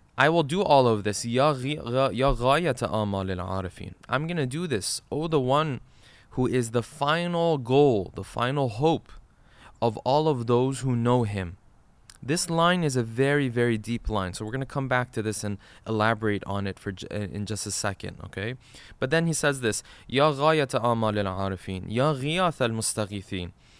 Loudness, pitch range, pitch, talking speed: -26 LUFS, 105-140 Hz, 120 Hz, 145 wpm